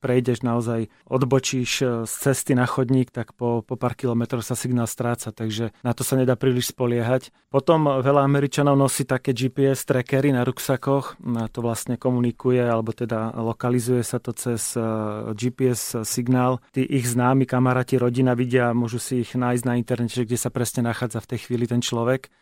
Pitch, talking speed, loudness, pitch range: 125 Hz, 170 wpm, -23 LUFS, 120-130 Hz